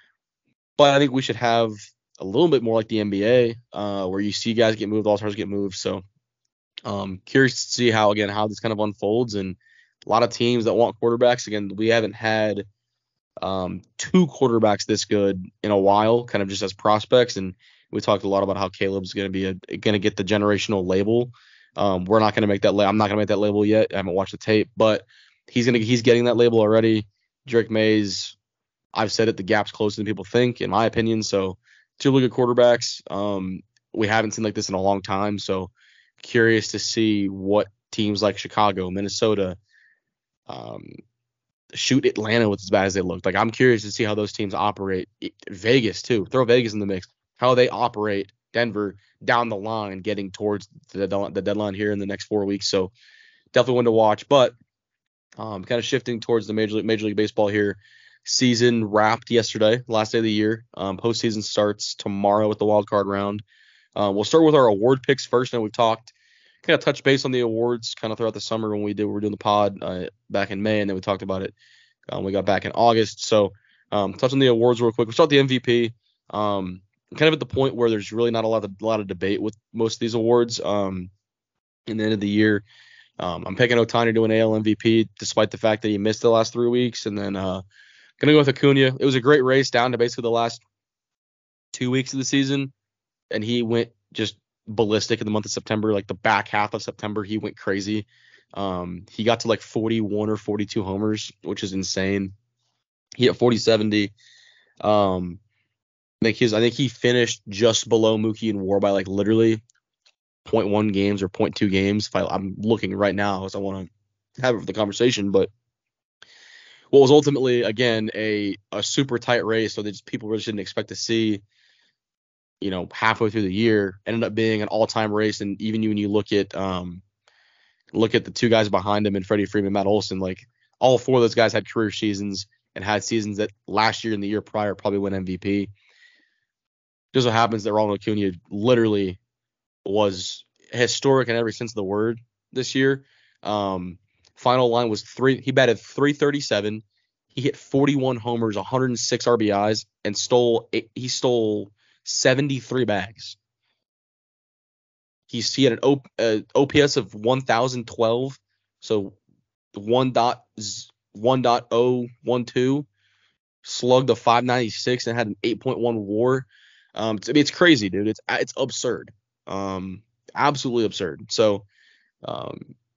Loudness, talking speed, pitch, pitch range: -22 LUFS, 200 wpm, 110 Hz, 100-120 Hz